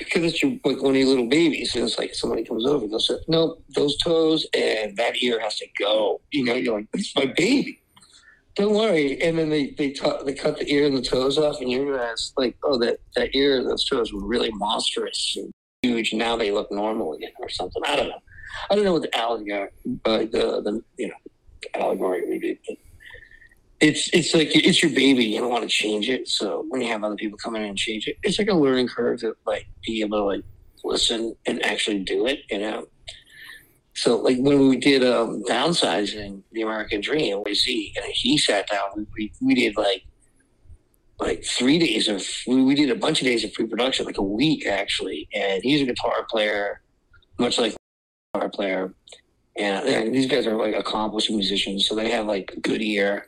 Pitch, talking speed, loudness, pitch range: 135 Hz, 215 wpm, -22 LUFS, 110-175 Hz